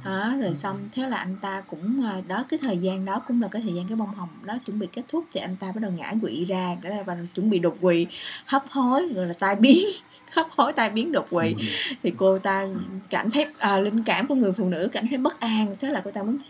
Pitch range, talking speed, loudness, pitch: 190-255 Hz, 260 wpm, -25 LUFS, 205 Hz